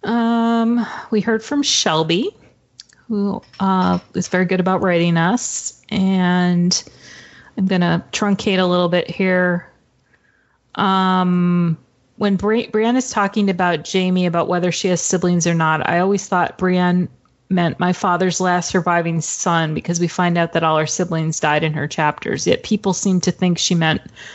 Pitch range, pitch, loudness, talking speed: 170-195 Hz, 180 Hz, -18 LUFS, 160 wpm